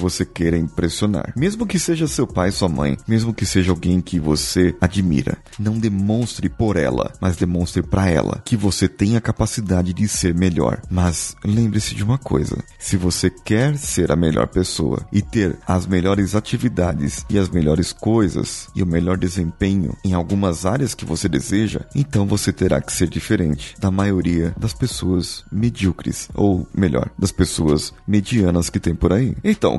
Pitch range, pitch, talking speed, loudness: 85-105 Hz, 95 Hz, 170 wpm, -19 LUFS